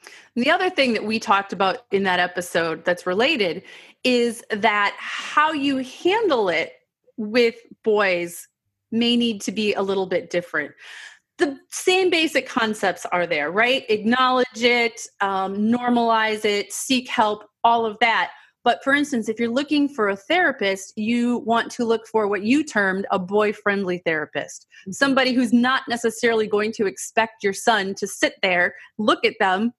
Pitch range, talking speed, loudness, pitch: 200-255 Hz, 165 wpm, -21 LUFS, 225 Hz